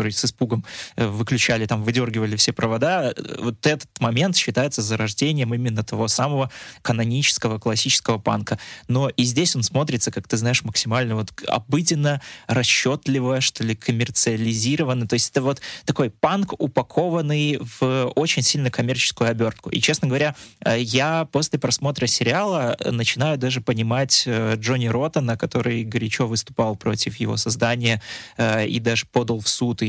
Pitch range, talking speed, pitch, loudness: 115-135 Hz, 140 wpm, 120 Hz, -21 LUFS